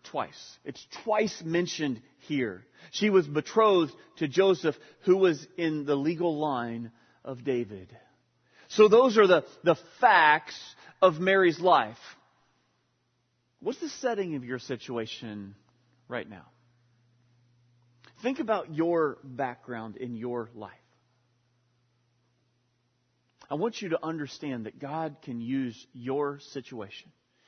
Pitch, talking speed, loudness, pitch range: 130 Hz, 115 wpm, -27 LUFS, 120-165 Hz